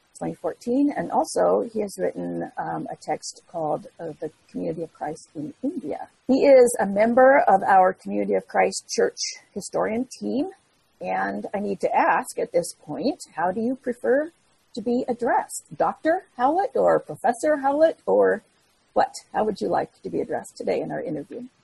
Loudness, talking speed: -23 LUFS, 170 wpm